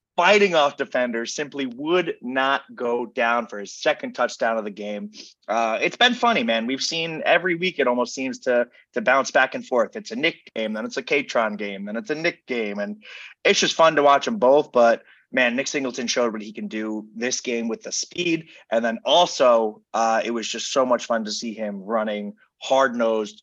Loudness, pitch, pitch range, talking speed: -22 LUFS, 115 Hz, 110-140 Hz, 215 wpm